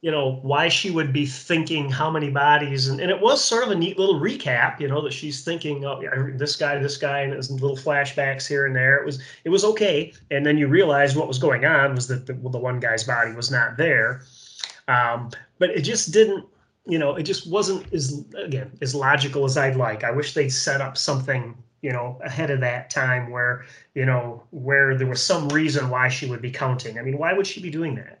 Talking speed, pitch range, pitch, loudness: 235 wpm, 130-155 Hz, 140 Hz, -22 LUFS